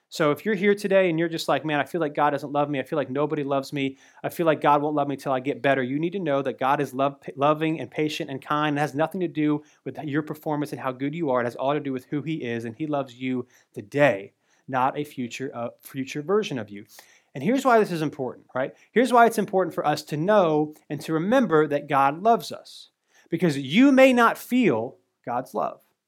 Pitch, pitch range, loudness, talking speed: 150 Hz, 140-165 Hz, -24 LUFS, 255 wpm